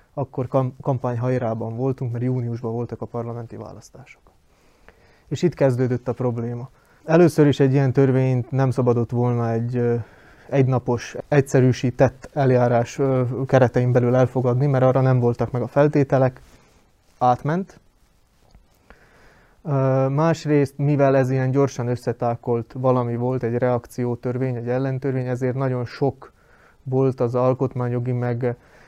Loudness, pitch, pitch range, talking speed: -21 LUFS, 125 Hz, 120-135 Hz, 115 wpm